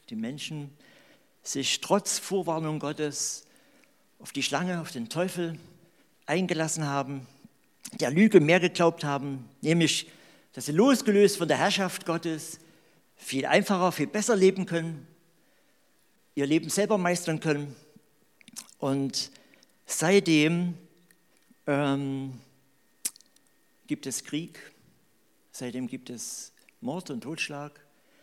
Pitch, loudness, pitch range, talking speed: 160 Hz, -27 LUFS, 145-185 Hz, 105 wpm